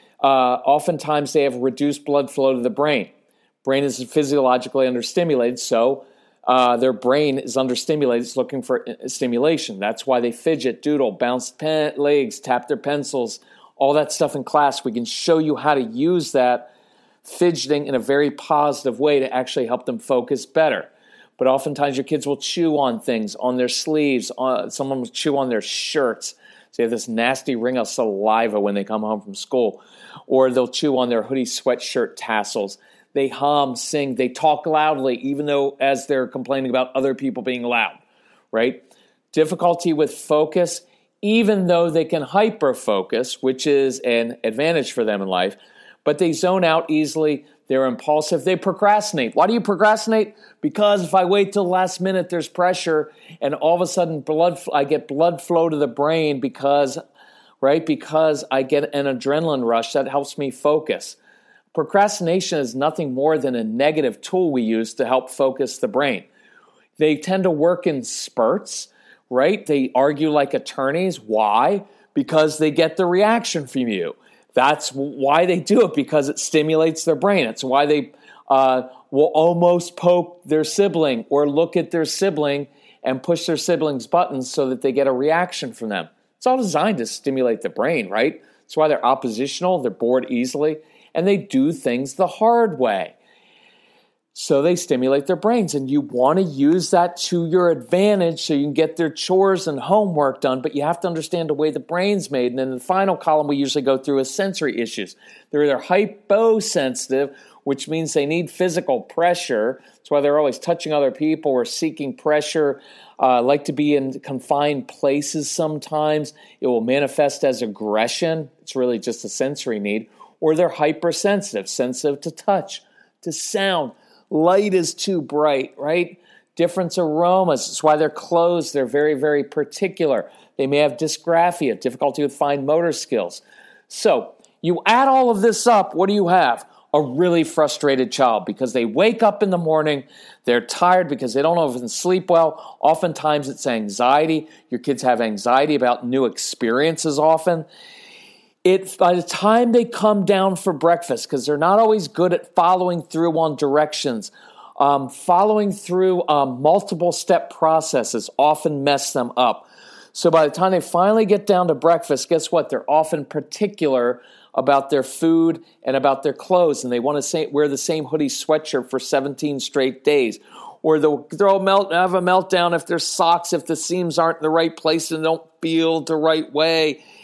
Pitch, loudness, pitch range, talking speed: 155 Hz, -19 LUFS, 135-175 Hz, 175 wpm